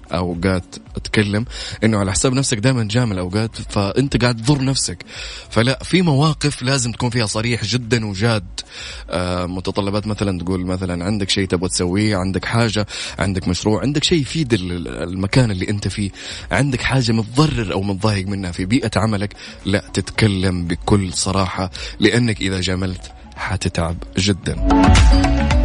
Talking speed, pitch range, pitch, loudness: 140 wpm, 95-115 Hz, 100 Hz, -19 LUFS